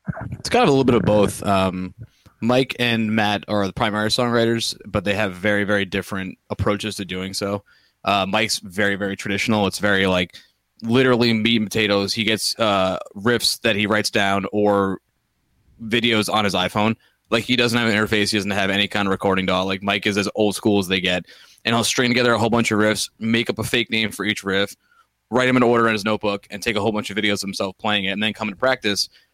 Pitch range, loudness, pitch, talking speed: 100-115 Hz, -20 LUFS, 105 Hz, 235 wpm